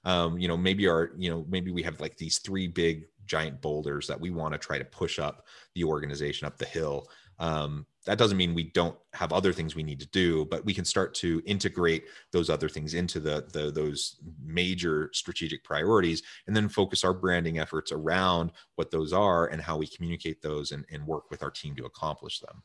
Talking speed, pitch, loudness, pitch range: 215 wpm, 85 Hz, -30 LUFS, 75-90 Hz